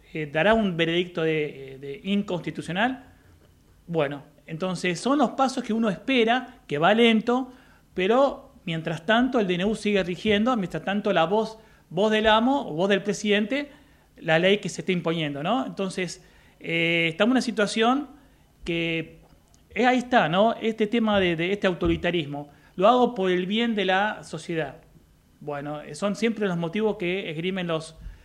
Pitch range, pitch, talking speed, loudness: 165-220 Hz, 195 Hz, 160 wpm, -24 LUFS